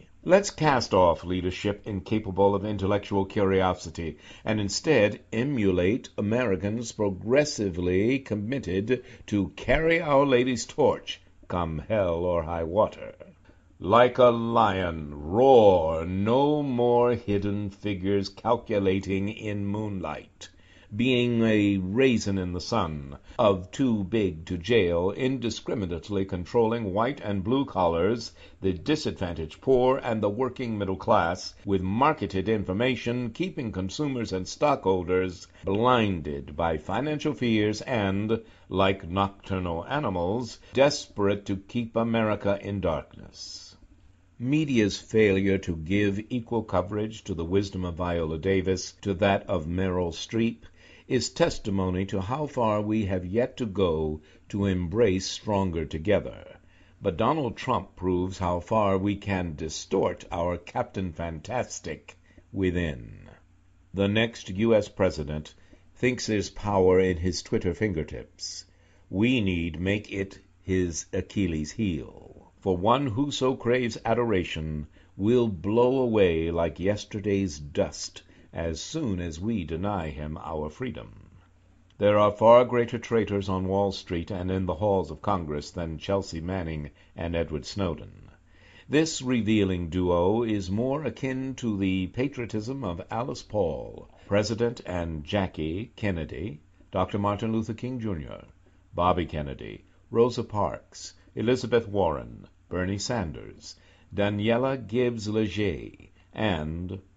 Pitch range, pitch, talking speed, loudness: 90-115 Hz, 100 Hz, 120 wpm, -27 LUFS